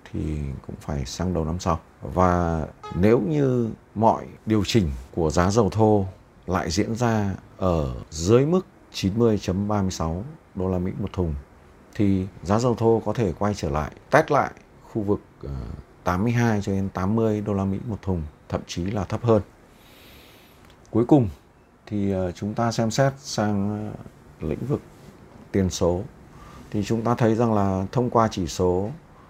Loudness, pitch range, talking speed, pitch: -24 LUFS, 90-115 Hz, 160 wpm, 100 Hz